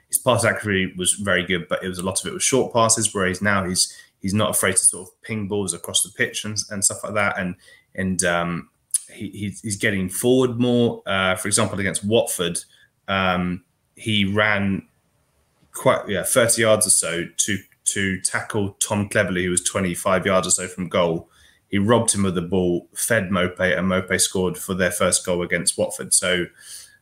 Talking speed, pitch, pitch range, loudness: 200 wpm, 100 Hz, 90-110 Hz, -20 LUFS